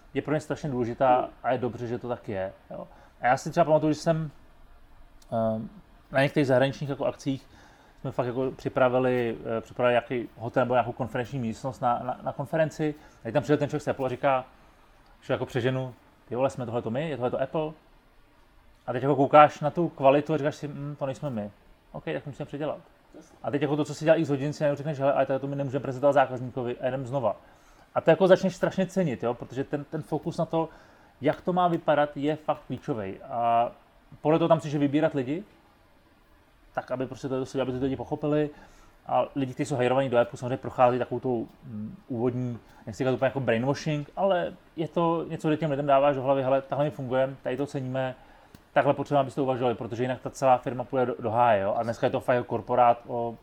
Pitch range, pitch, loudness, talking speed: 125-150 Hz, 135 Hz, -27 LUFS, 225 wpm